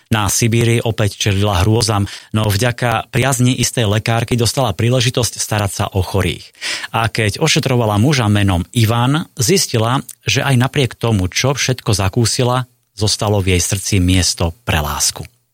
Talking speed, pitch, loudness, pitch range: 145 wpm, 115 Hz, -15 LUFS, 105-125 Hz